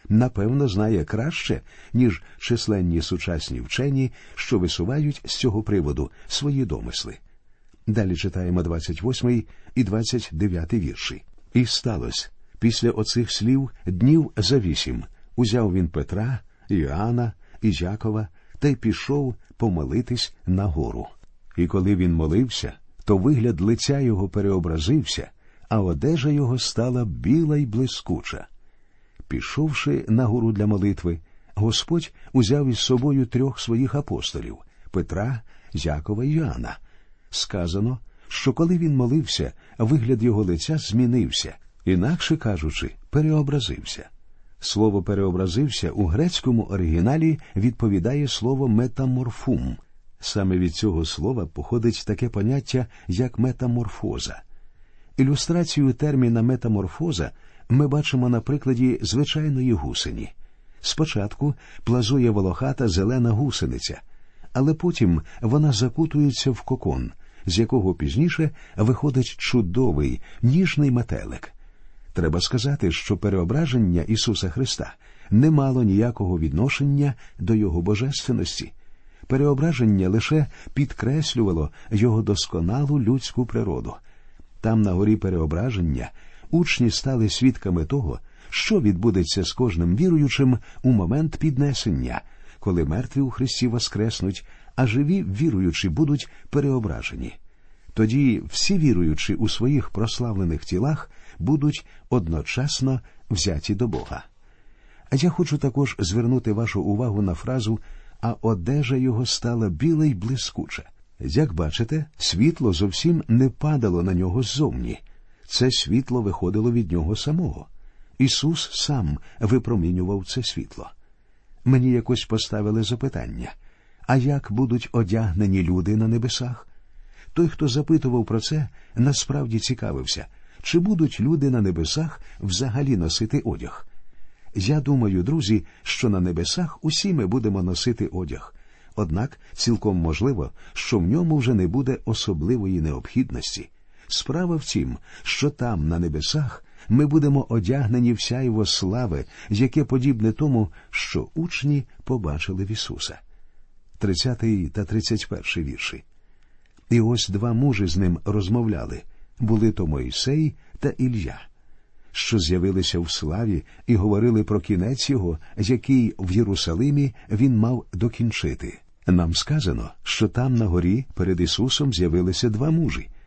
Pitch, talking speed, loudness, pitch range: 115 Hz, 115 wpm, -23 LUFS, 95-130 Hz